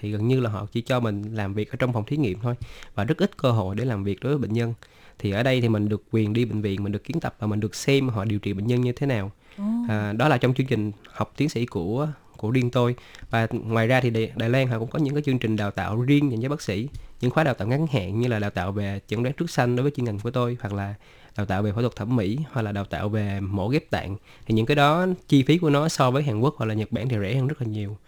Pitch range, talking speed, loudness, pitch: 105-130 Hz, 315 wpm, -25 LUFS, 115 Hz